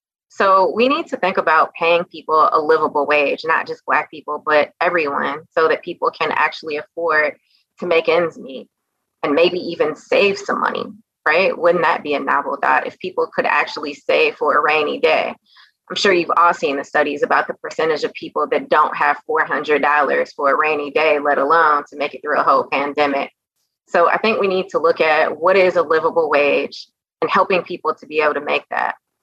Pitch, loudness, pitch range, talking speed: 170 Hz, -17 LUFS, 150-235 Hz, 205 wpm